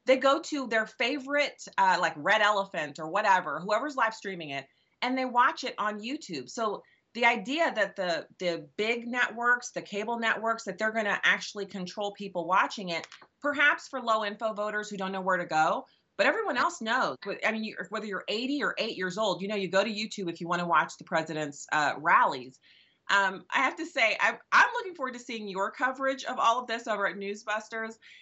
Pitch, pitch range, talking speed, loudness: 220 Hz, 195-255 Hz, 215 wpm, -29 LUFS